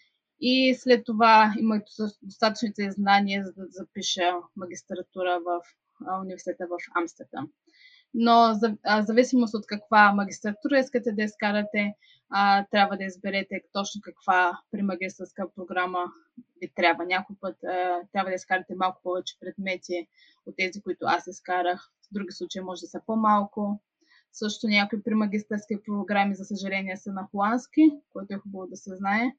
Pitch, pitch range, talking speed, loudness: 200 Hz, 185-220 Hz, 135 wpm, -26 LUFS